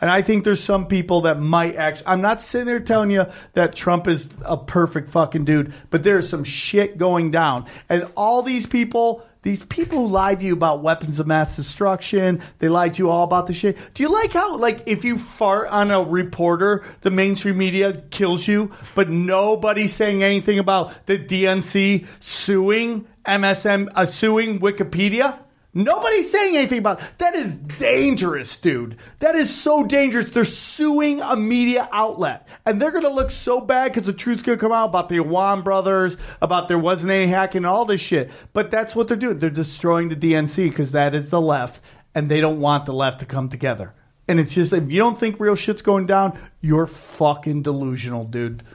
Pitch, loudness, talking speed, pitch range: 190 Hz, -19 LUFS, 195 wpm, 165-220 Hz